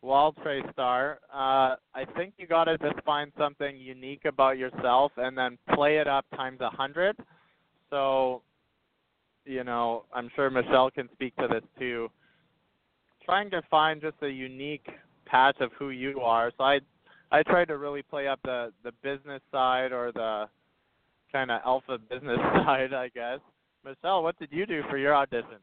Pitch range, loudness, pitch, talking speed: 125-145 Hz, -28 LUFS, 135 Hz, 170 wpm